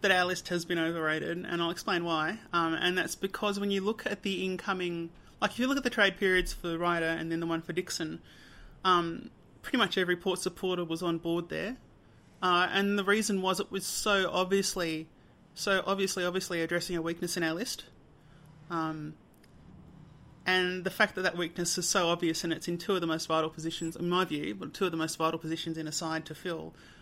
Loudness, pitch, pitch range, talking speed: -31 LUFS, 175 Hz, 165-190 Hz, 220 wpm